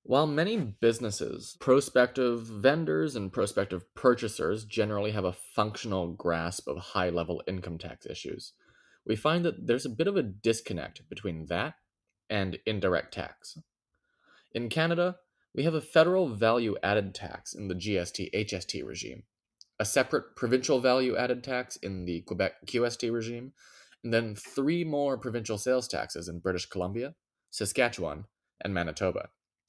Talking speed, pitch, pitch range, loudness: 145 wpm, 110 Hz, 95-125 Hz, -30 LUFS